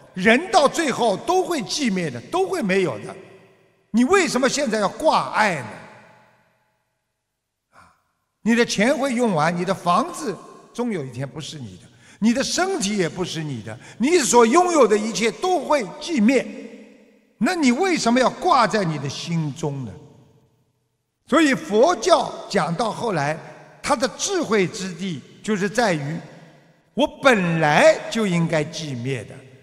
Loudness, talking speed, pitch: -20 LUFS, 210 characters per minute, 215 Hz